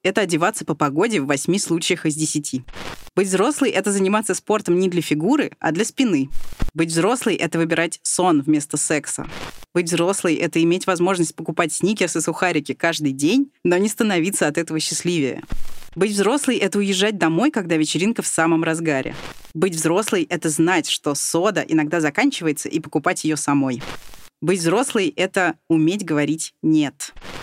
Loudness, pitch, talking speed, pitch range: -20 LUFS, 170 Hz, 160 wpm, 155-190 Hz